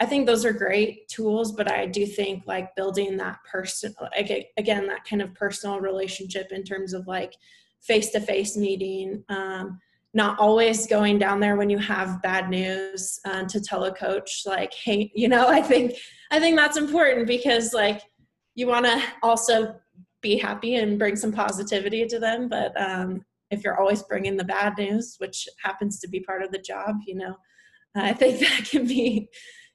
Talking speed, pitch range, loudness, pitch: 185 wpm, 195-230 Hz, -24 LUFS, 205 Hz